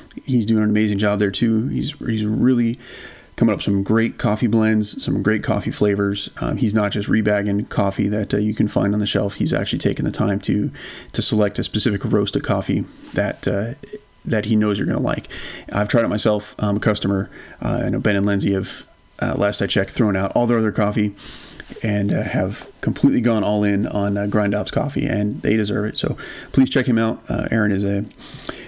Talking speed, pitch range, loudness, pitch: 220 wpm, 100-115 Hz, -20 LUFS, 105 Hz